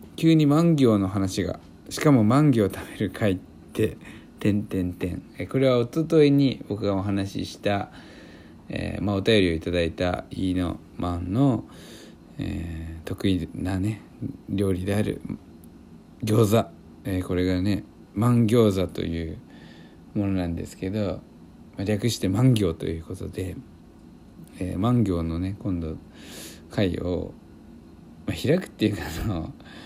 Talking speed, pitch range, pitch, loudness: 235 characters per minute, 85-110 Hz, 95 Hz, -25 LUFS